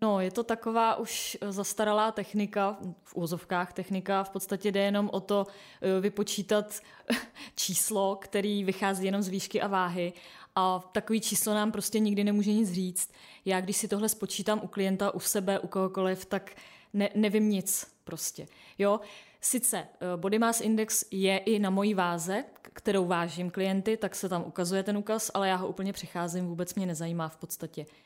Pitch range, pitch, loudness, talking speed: 185-210 Hz, 200 Hz, -30 LUFS, 170 wpm